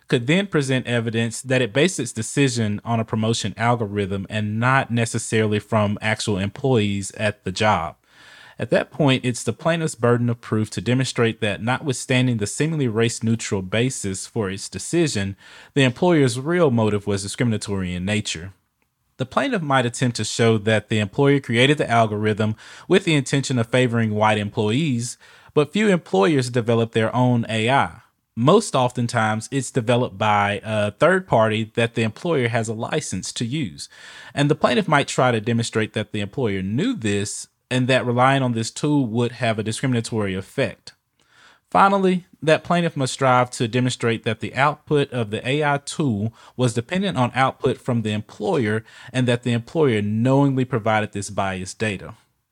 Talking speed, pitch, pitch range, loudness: 165 wpm, 120 Hz, 110-135 Hz, -21 LUFS